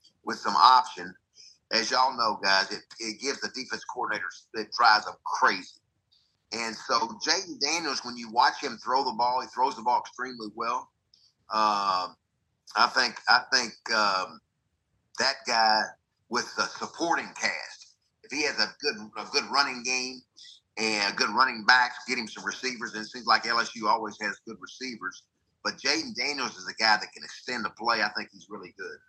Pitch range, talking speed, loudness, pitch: 110-130 Hz, 180 wpm, -27 LUFS, 120 Hz